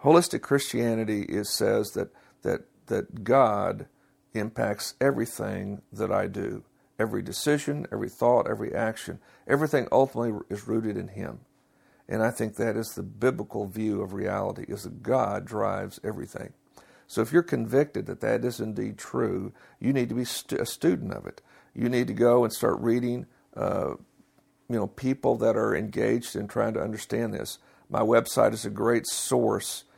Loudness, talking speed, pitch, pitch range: -27 LUFS, 165 wpm, 120 Hz, 110-135 Hz